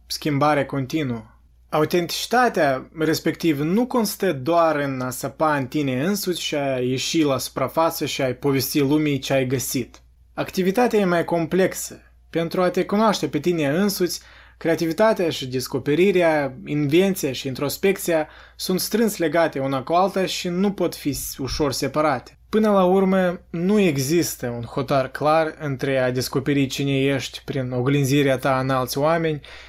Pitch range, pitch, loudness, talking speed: 135-175 Hz, 150 Hz, -21 LUFS, 150 wpm